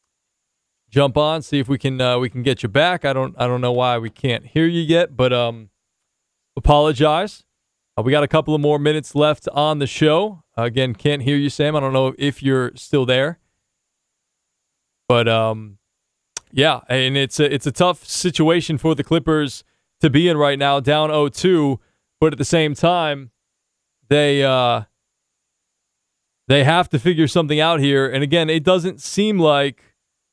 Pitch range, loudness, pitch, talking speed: 130-155 Hz, -18 LUFS, 145 Hz, 180 wpm